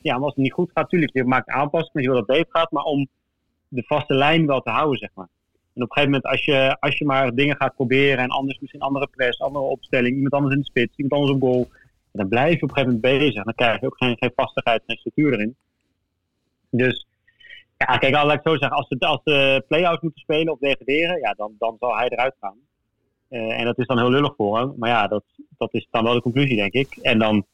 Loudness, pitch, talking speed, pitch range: -20 LUFS, 135 Hz, 260 wpm, 120-145 Hz